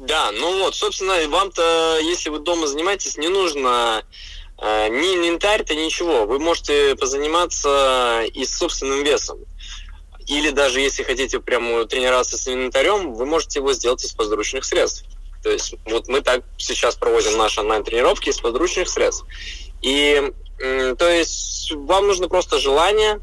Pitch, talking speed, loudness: 175 Hz, 150 wpm, -19 LUFS